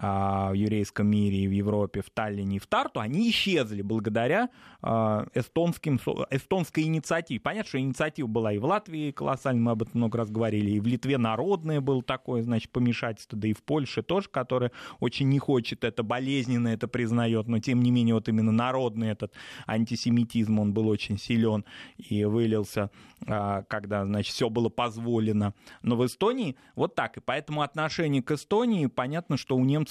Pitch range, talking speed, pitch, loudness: 110-135 Hz, 175 wpm, 120 Hz, -28 LUFS